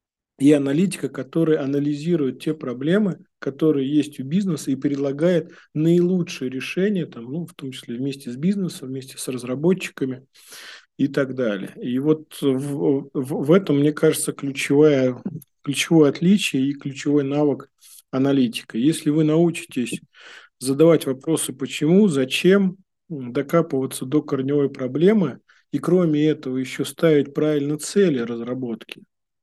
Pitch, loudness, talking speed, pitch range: 145 Hz, -21 LUFS, 125 wpm, 135-165 Hz